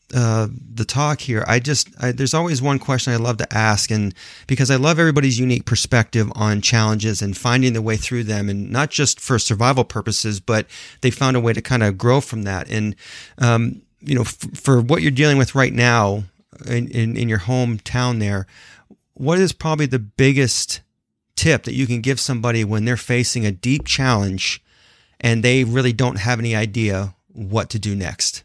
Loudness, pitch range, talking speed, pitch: -19 LUFS, 110-130 Hz, 195 wpm, 120 Hz